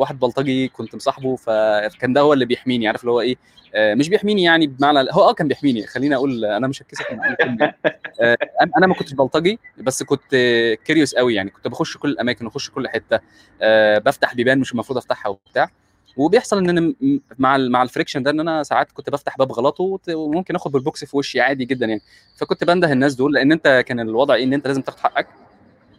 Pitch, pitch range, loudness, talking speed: 135 Hz, 120-155 Hz, -18 LUFS, 200 wpm